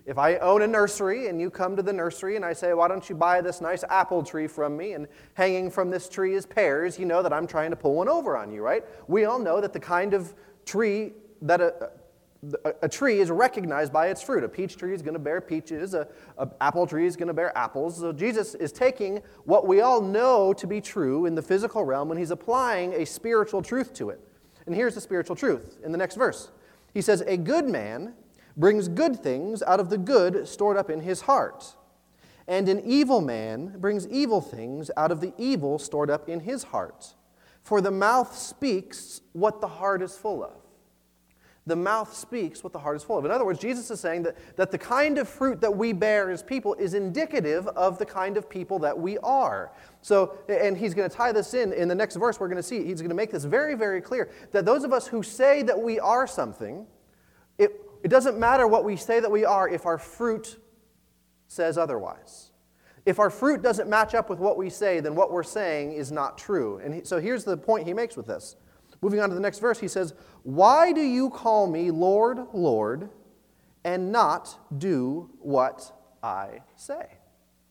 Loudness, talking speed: -25 LUFS, 220 wpm